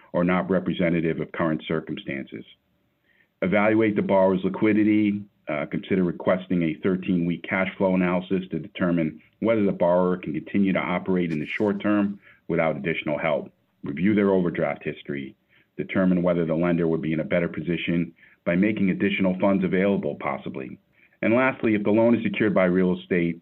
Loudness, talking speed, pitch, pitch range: -24 LUFS, 165 wpm, 95 Hz, 85-100 Hz